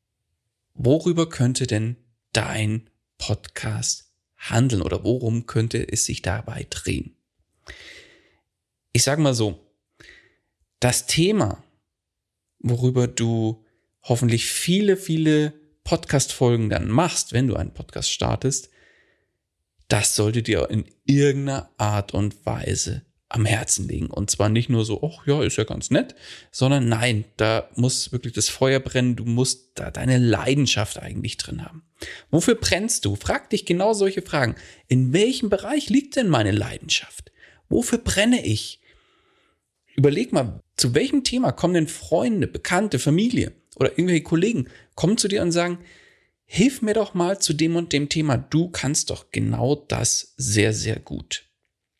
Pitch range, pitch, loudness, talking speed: 110-160 Hz, 125 Hz, -22 LUFS, 140 wpm